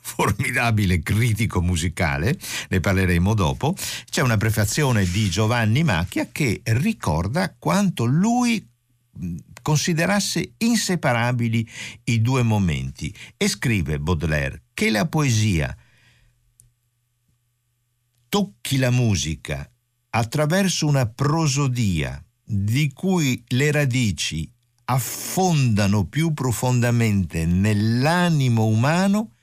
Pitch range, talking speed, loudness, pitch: 105-145 Hz, 85 wpm, -21 LUFS, 120 Hz